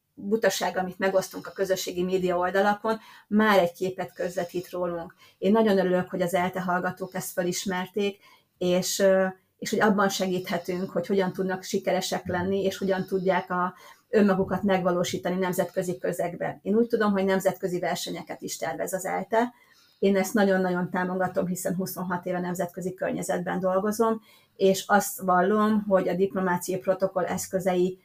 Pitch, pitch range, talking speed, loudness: 185 Hz, 180-195 Hz, 145 wpm, -26 LUFS